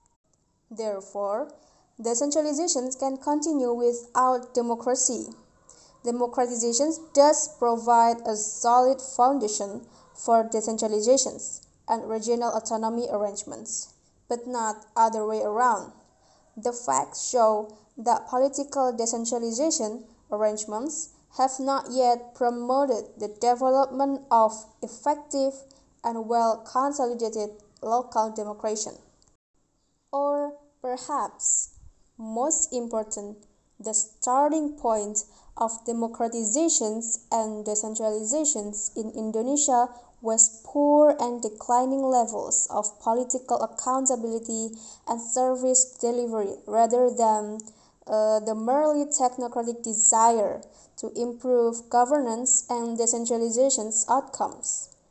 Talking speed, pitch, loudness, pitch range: 85 wpm, 235 Hz, -25 LUFS, 220-260 Hz